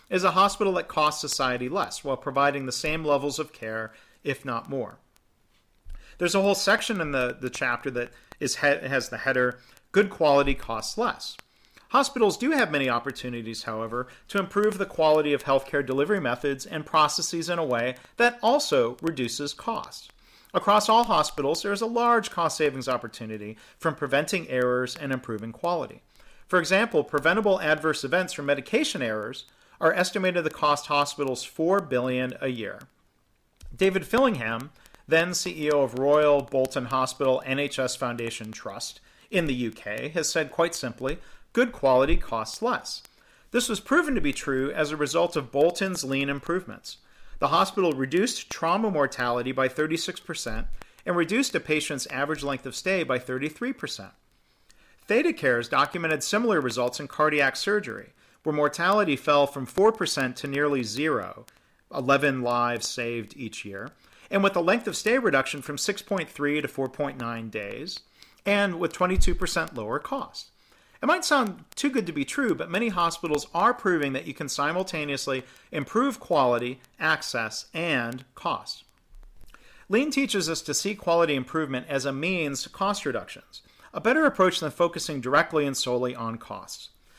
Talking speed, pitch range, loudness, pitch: 155 wpm, 130-185 Hz, -26 LUFS, 145 Hz